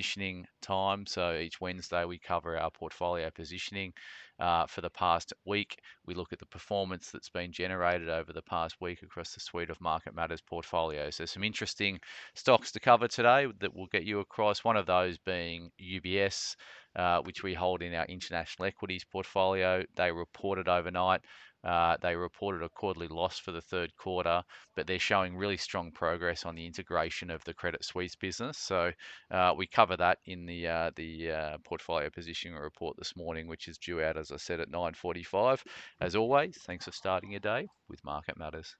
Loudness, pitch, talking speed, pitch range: -33 LUFS, 90 Hz, 185 wpm, 85-95 Hz